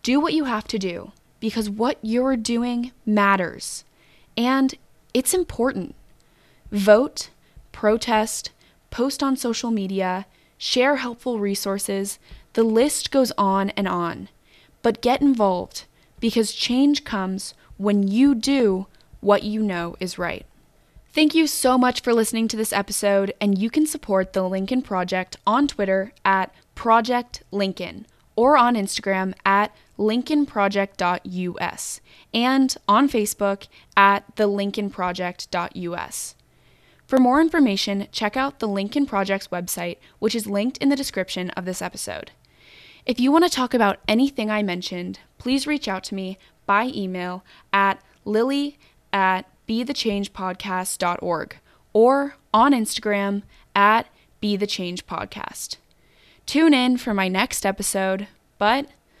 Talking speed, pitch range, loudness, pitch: 130 wpm, 195-250 Hz, -22 LUFS, 210 Hz